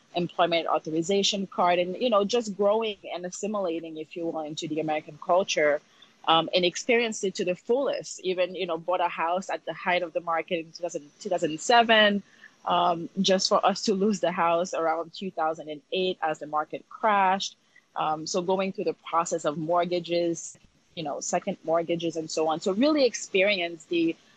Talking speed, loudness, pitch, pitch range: 175 wpm, -26 LUFS, 175 Hz, 165-195 Hz